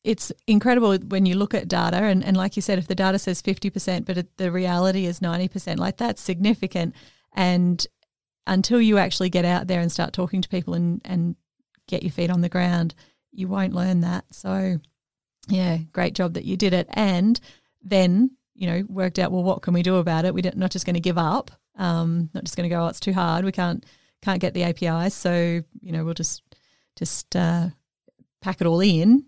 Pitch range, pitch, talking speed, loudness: 175-195 Hz, 185 Hz, 215 wpm, -23 LUFS